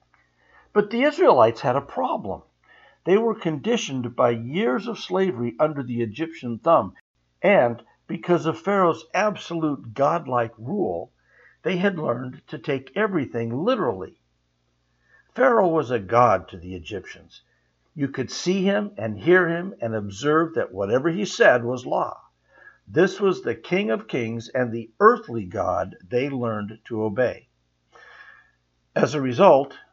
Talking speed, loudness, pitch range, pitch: 140 wpm, -23 LUFS, 115-180 Hz, 135 Hz